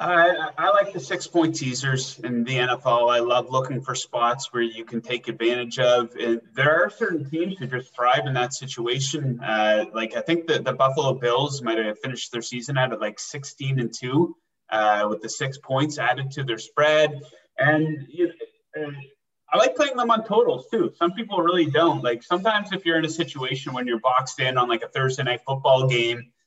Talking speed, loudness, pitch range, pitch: 205 wpm, -23 LUFS, 120-160 Hz, 130 Hz